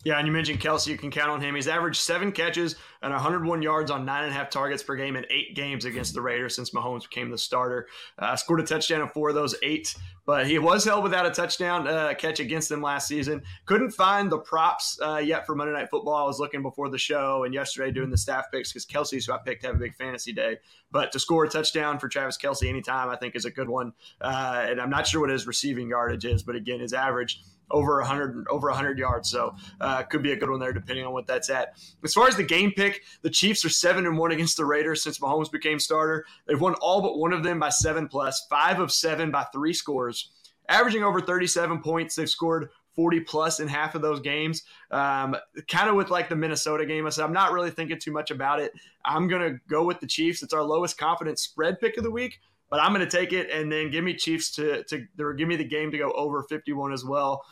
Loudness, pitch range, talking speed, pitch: -26 LUFS, 140-165 Hz, 250 wpm, 155 Hz